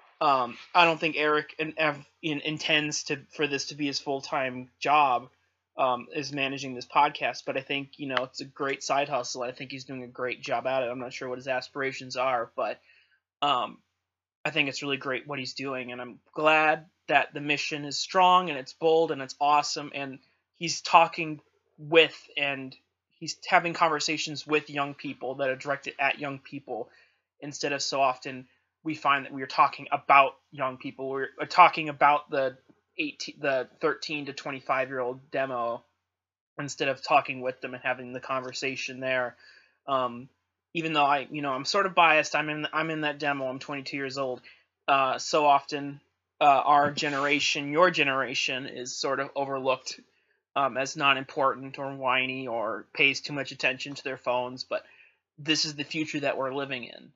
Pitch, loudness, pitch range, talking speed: 140 Hz, -27 LUFS, 130-150 Hz, 185 wpm